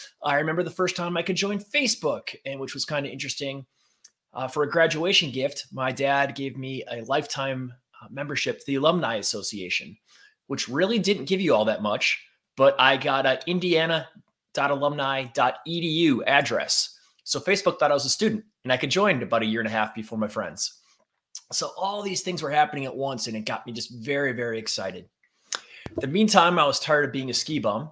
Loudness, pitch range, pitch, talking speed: -25 LUFS, 130-170 Hz, 140 Hz, 200 wpm